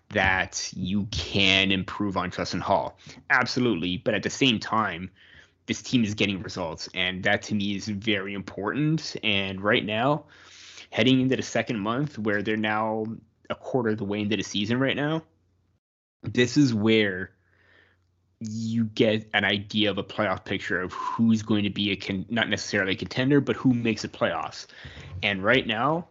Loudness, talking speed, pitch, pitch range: -25 LUFS, 175 wpm, 105 Hz, 95-115 Hz